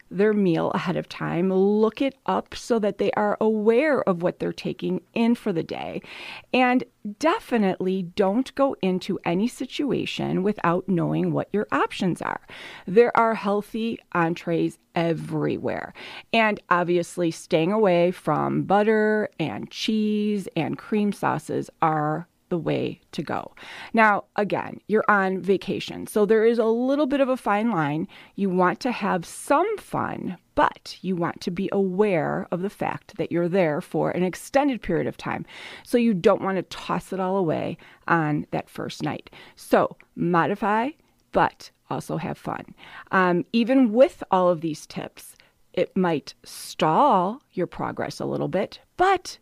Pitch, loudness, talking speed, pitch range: 195 Hz, -24 LUFS, 155 wpm, 175-225 Hz